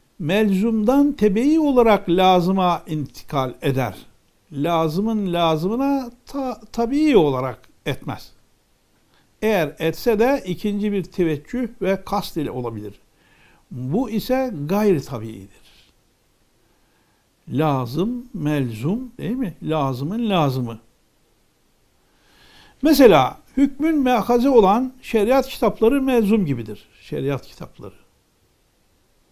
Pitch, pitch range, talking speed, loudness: 195 Hz, 150-240 Hz, 85 wpm, -20 LUFS